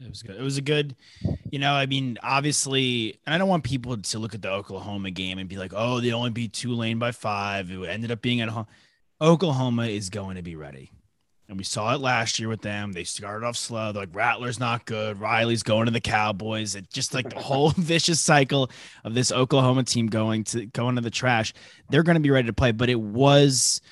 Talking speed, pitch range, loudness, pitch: 235 wpm, 105-130 Hz, -24 LUFS, 115 Hz